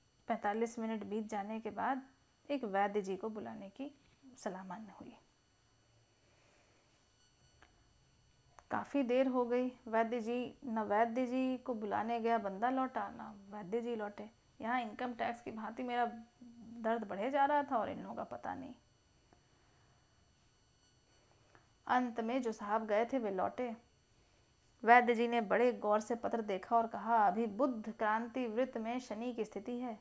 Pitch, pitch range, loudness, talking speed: 230 Hz, 210-245 Hz, -37 LUFS, 155 wpm